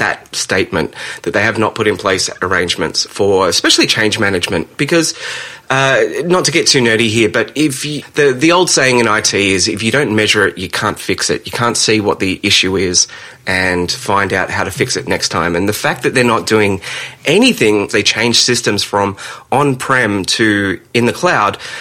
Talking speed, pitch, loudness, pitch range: 205 wpm, 115 Hz, -13 LUFS, 100-150 Hz